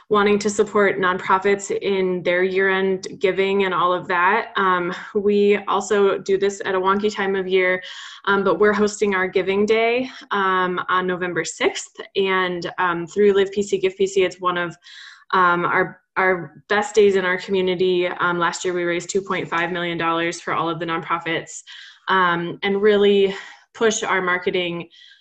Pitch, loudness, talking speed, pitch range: 190 Hz, -20 LUFS, 165 wpm, 180-200 Hz